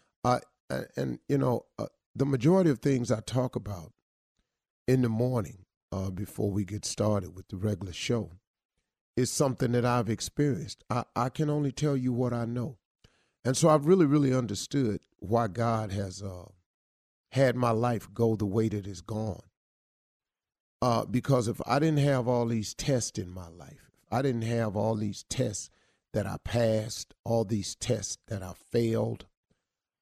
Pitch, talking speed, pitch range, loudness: 115 Hz, 170 wpm, 100-125 Hz, -29 LUFS